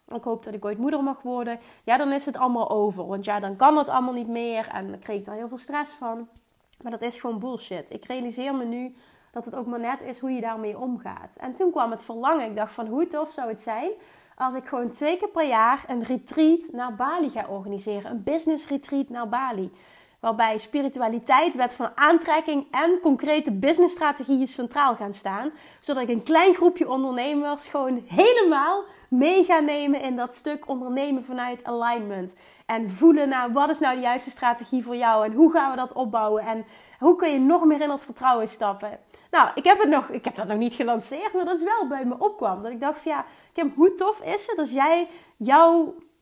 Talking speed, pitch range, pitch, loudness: 220 wpm, 235-300 Hz, 255 Hz, -24 LUFS